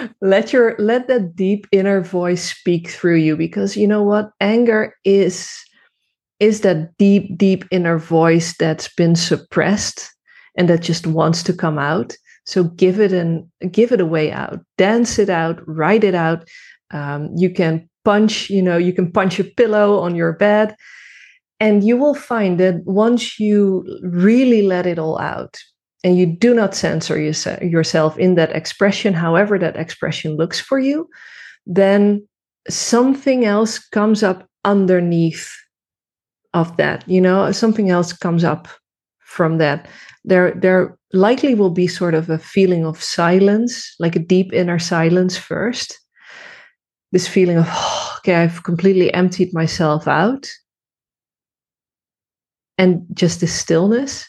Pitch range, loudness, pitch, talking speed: 170-210 Hz, -16 LUFS, 185 Hz, 150 wpm